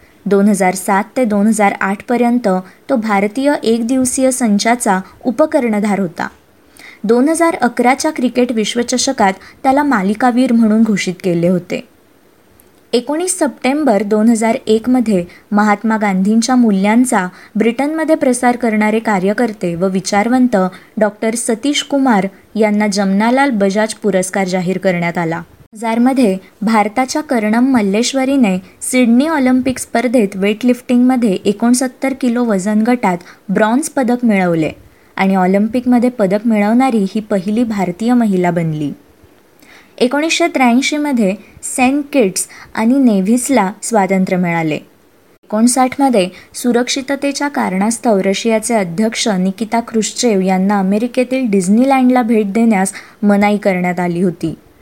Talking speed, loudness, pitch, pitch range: 105 wpm, -14 LUFS, 225 Hz, 200-255 Hz